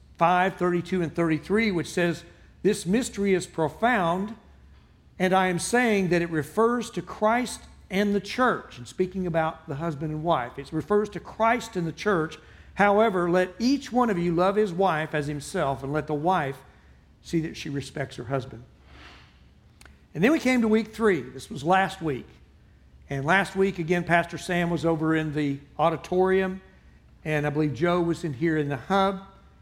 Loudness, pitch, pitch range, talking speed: -25 LUFS, 175 Hz, 155-195 Hz, 180 wpm